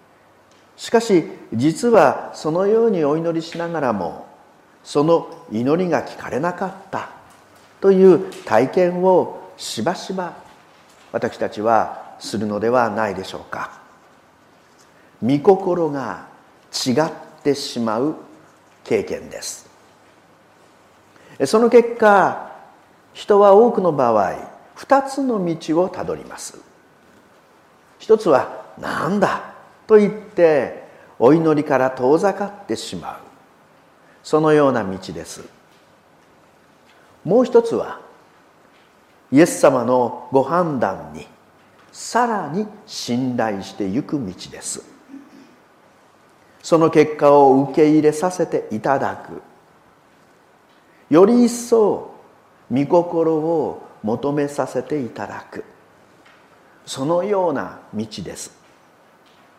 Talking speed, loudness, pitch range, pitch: 185 characters per minute, -18 LUFS, 140-210 Hz, 165 Hz